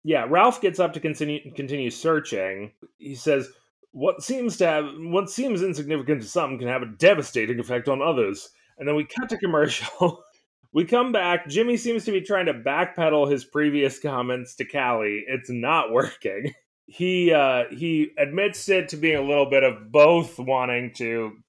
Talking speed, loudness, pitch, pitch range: 180 wpm, -23 LUFS, 150 Hz, 130-185 Hz